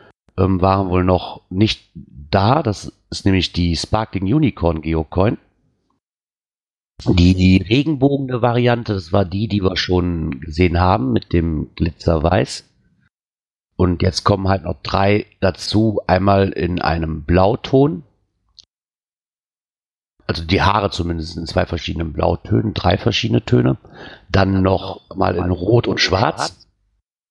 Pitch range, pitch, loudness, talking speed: 85-105 Hz, 95 Hz, -18 LUFS, 125 wpm